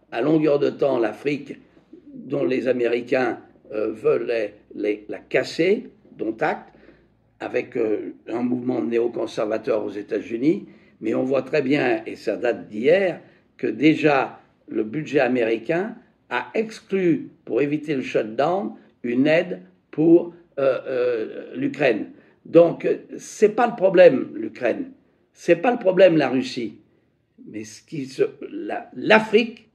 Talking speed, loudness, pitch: 140 wpm, -22 LUFS, 190 Hz